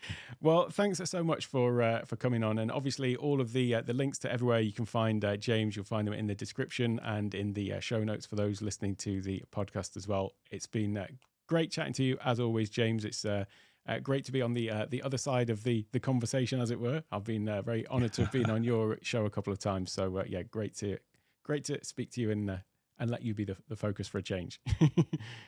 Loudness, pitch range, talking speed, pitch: -34 LUFS, 105-125 Hz, 260 wpm, 115 Hz